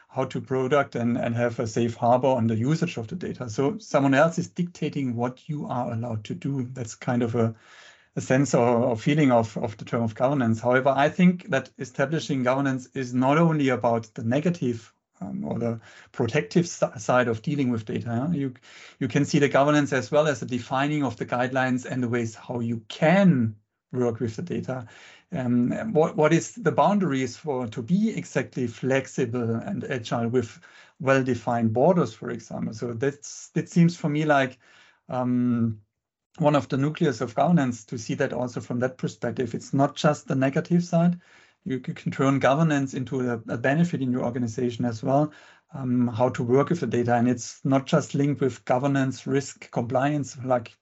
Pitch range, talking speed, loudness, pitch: 120-145 Hz, 195 wpm, -25 LUFS, 130 Hz